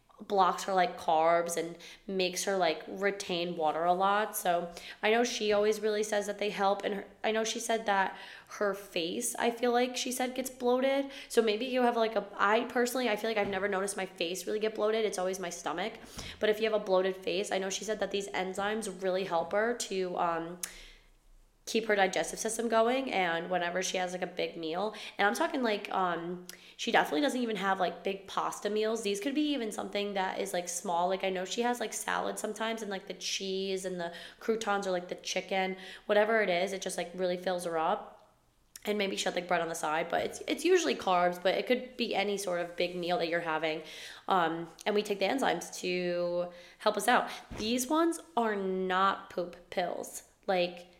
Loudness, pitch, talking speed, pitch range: -32 LUFS, 195 Hz, 220 wpm, 180-220 Hz